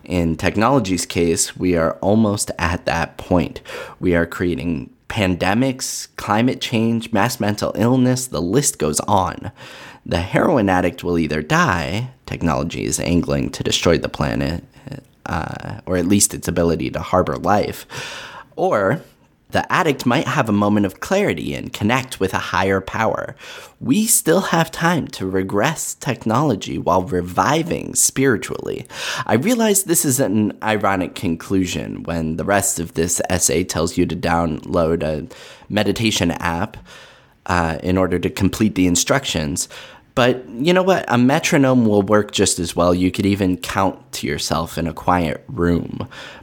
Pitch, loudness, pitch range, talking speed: 95 Hz, -19 LUFS, 85-125 Hz, 150 wpm